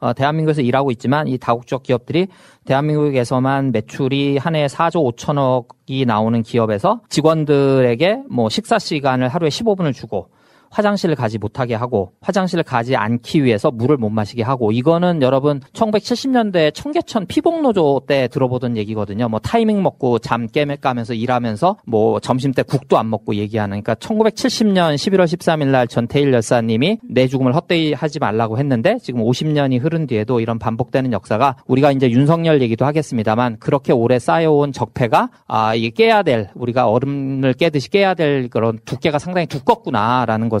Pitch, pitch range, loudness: 135 Hz, 120-160 Hz, -17 LUFS